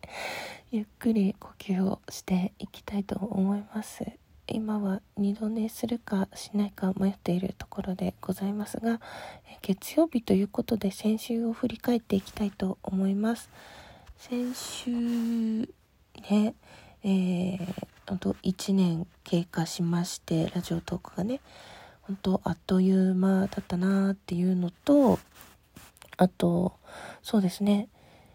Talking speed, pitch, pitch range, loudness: 255 characters per minute, 195 Hz, 185-220 Hz, -29 LUFS